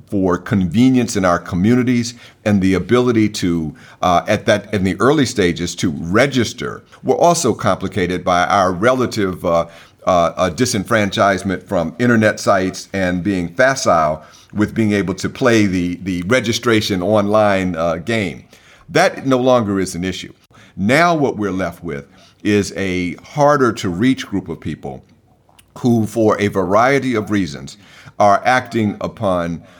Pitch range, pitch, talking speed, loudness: 90-115 Hz, 100 Hz, 145 wpm, -16 LUFS